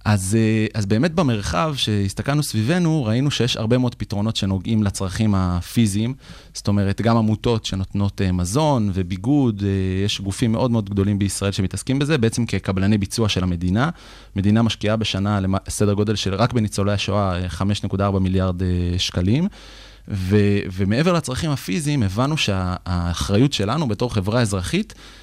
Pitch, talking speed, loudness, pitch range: 105 Hz, 140 wpm, -21 LUFS, 95-115 Hz